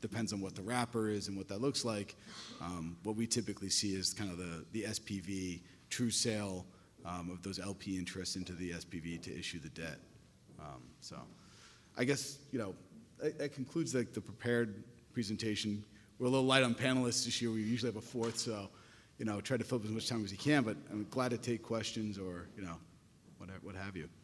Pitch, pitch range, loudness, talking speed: 110 Hz, 95-120 Hz, -38 LUFS, 220 wpm